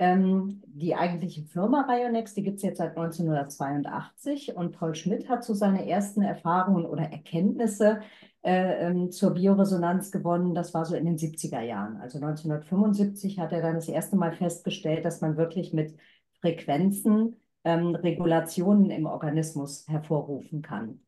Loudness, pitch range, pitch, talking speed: -28 LUFS, 160-195 Hz, 175 Hz, 145 wpm